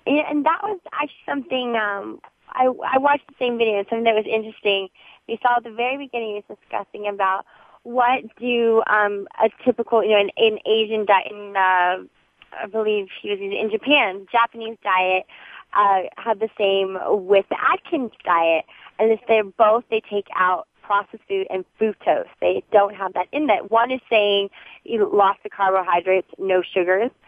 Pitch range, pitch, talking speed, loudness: 195-240 Hz, 220 Hz, 180 wpm, -21 LUFS